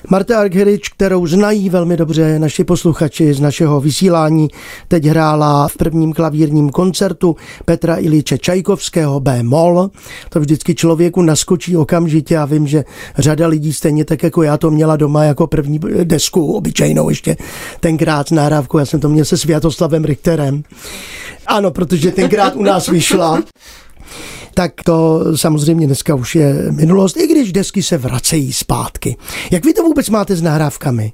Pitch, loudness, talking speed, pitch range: 165 Hz, -13 LUFS, 150 wpm, 155-180 Hz